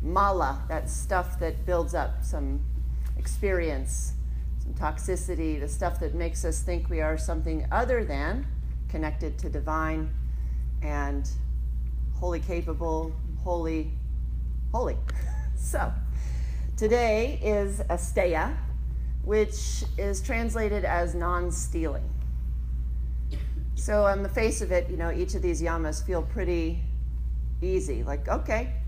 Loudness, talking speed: -29 LUFS, 110 wpm